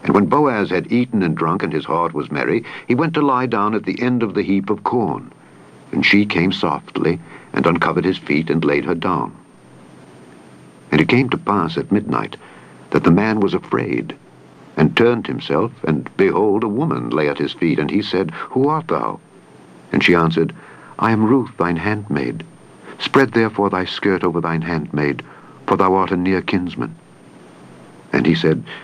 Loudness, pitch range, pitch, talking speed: -18 LUFS, 80-110 Hz, 95 Hz, 185 wpm